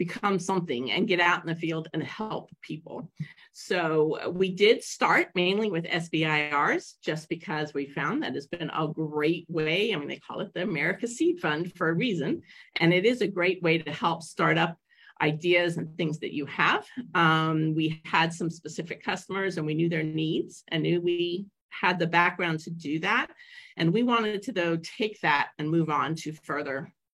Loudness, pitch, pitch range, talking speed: -27 LUFS, 165 Hz, 160-180 Hz, 195 wpm